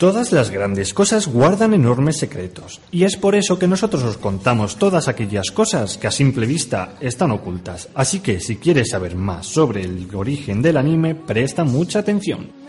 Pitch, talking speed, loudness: 135 Hz, 180 wpm, -18 LUFS